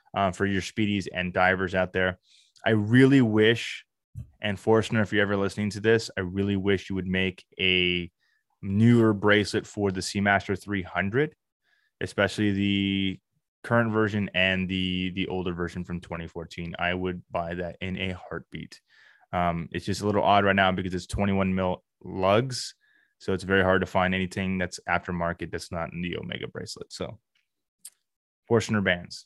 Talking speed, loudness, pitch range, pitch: 165 wpm, -26 LUFS, 90-105 Hz, 95 Hz